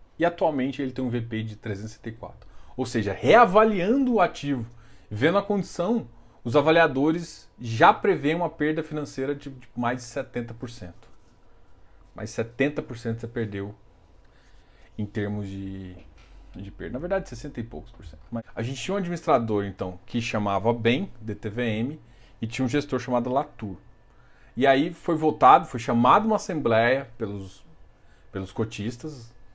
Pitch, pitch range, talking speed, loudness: 120 Hz, 105-145 Hz, 145 wpm, -25 LUFS